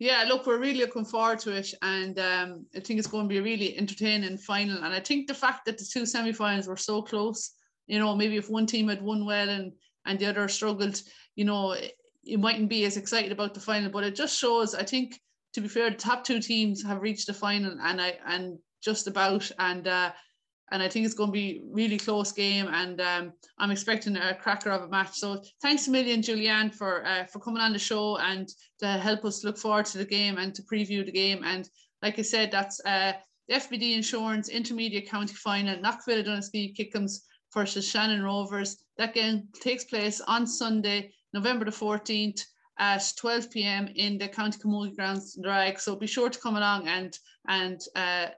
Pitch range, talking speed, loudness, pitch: 195-220 Hz, 210 wpm, -28 LUFS, 205 Hz